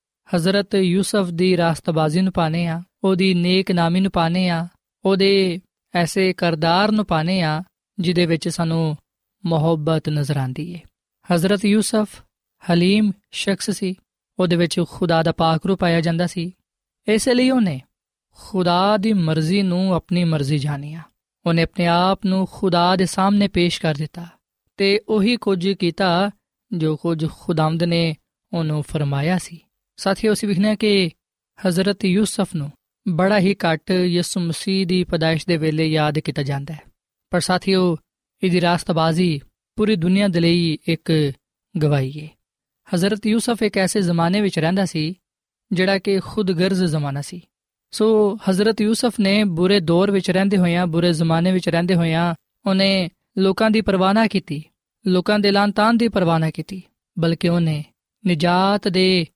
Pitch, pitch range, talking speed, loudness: 180 Hz, 165-195 Hz, 150 wpm, -19 LUFS